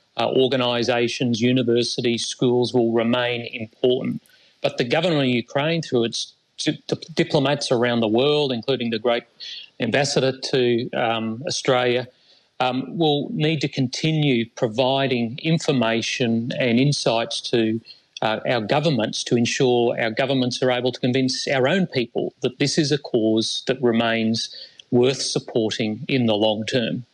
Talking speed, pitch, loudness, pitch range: 140 wpm, 125 Hz, -21 LUFS, 115-135 Hz